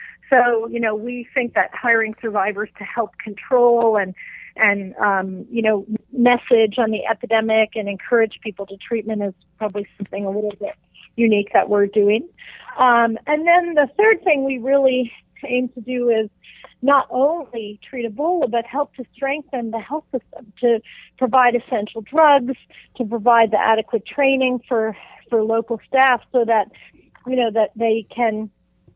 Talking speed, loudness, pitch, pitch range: 160 wpm, -19 LUFS, 230 Hz, 215-255 Hz